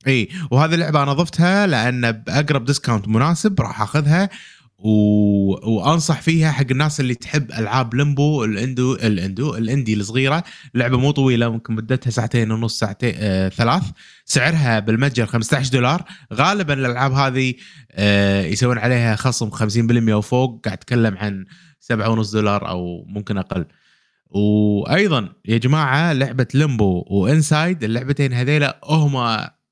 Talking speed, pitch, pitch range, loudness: 125 wpm, 125 Hz, 110-145 Hz, -18 LUFS